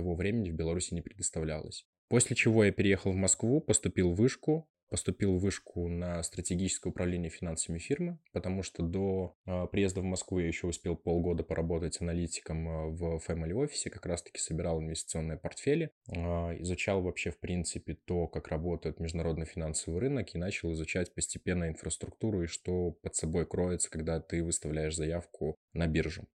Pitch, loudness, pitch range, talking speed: 85 Hz, -33 LUFS, 80-95 Hz, 160 wpm